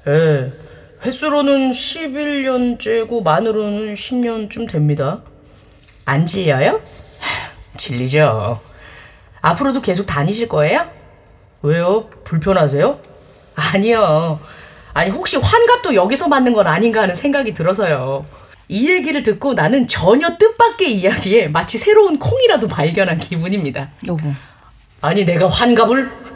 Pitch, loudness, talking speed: 190 Hz, -15 LUFS, 255 characters per minute